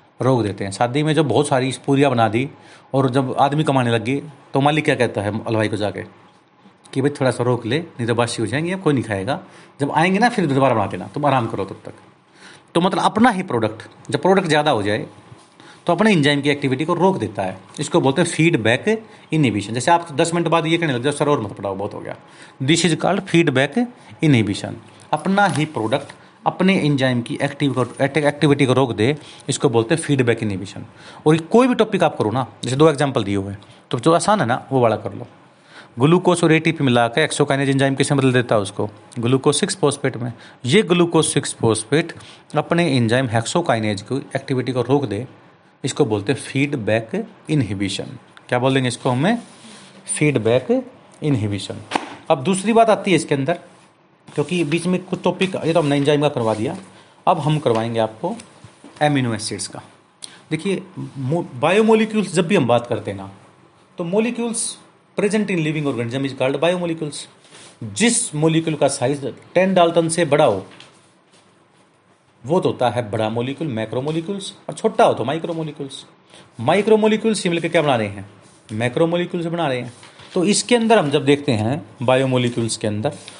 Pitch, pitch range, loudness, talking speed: 145 Hz, 120-170 Hz, -19 LUFS, 190 wpm